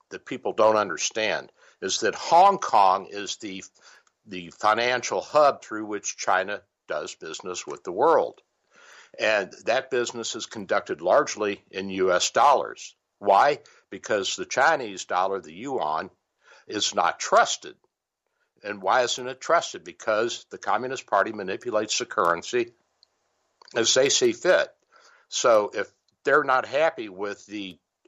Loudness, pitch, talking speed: -24 LUFS, 120 Hz, 135 wpm